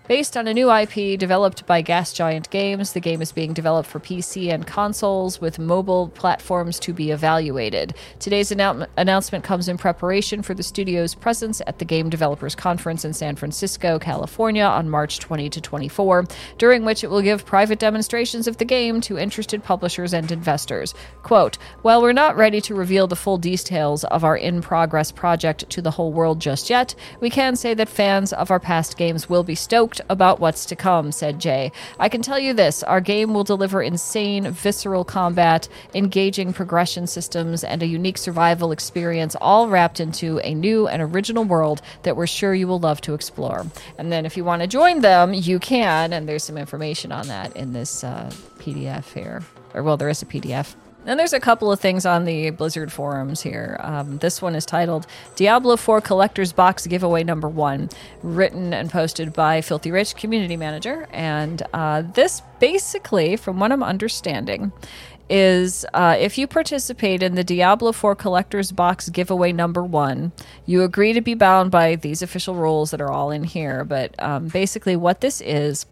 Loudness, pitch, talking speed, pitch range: -20 LUFS, 180 Hz, 190 wpm, 160-200 Hz